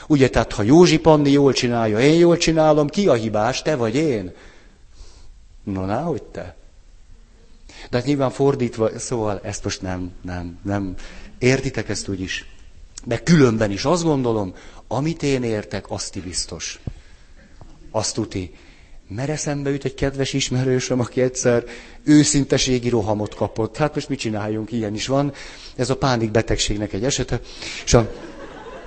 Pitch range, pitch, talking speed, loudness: 105-140 Hz, 120 Hz, 145 wpm, -20 LUFS